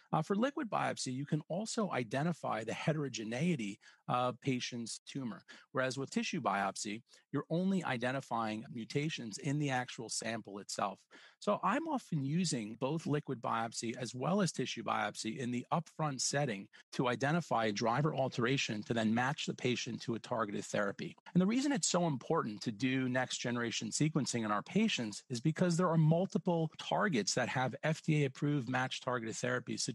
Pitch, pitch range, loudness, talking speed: 135 Hz, 120-165 Hz, -36 LUFS, 160 wpm